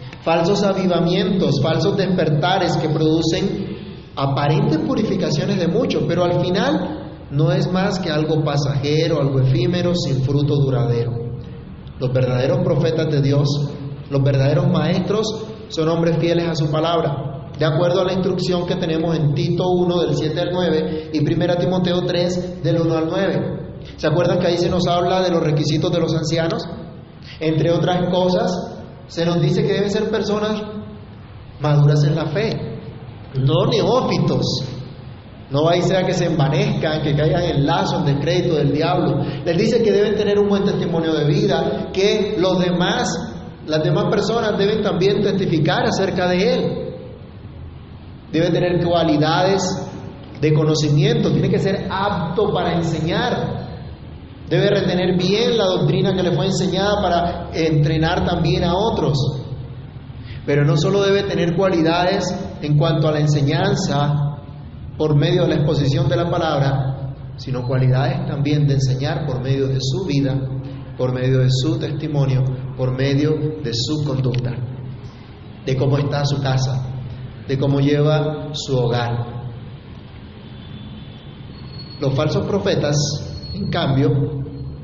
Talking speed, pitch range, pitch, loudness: 145 wpm, 140-180 Hz, 160 Hz, -19 LUFS